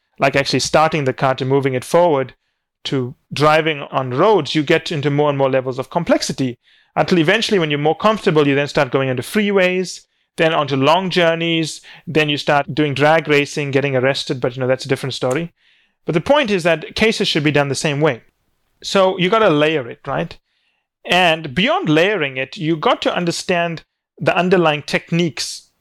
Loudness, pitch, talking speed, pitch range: -17 LUFS, 155 Hz, 195 wpm, 140-175 Hz